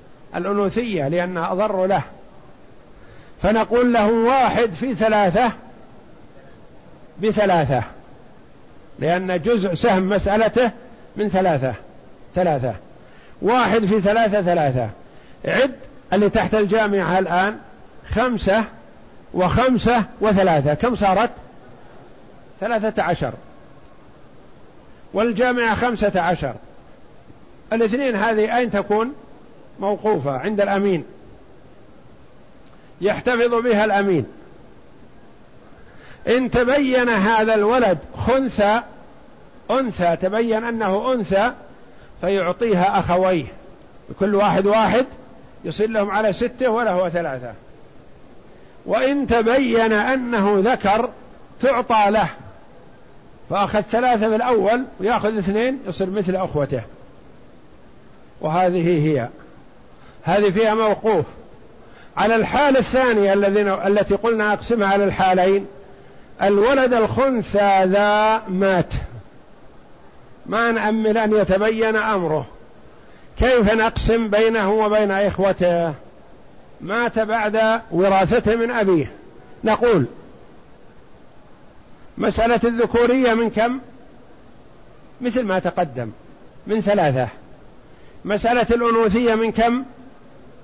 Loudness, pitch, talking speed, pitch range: -19 LUFS, 210 Hz, 85 wpm, 185-230 Hz